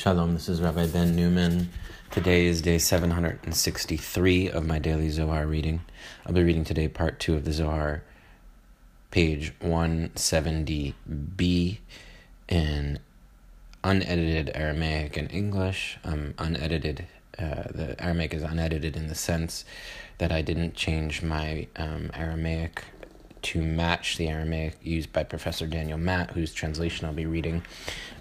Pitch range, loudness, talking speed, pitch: 80-85 Hz, -28 LUFS, 130 wpm, 80 Hz